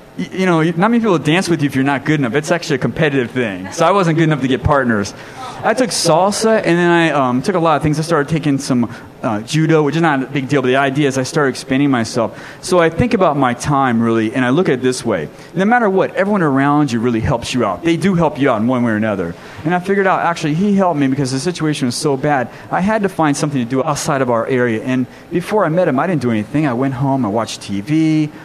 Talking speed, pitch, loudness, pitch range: 280 wpm, 145 Hz, -15 LUFS, 130-165 Hz